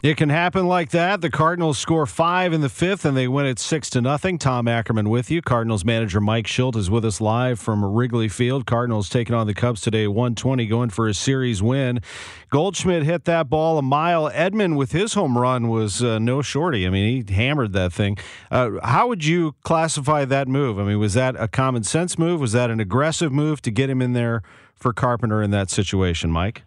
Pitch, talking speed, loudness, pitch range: 125 Hz, 220 wpm, -21 LUFS, 115-155 Hz